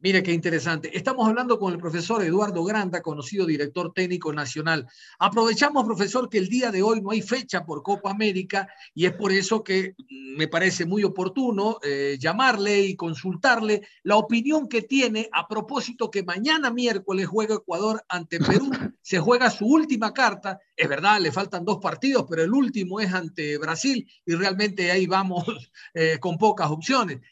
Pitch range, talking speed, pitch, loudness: 175-230 Hz, 170 wpm, 200 Hz, -24 LUFS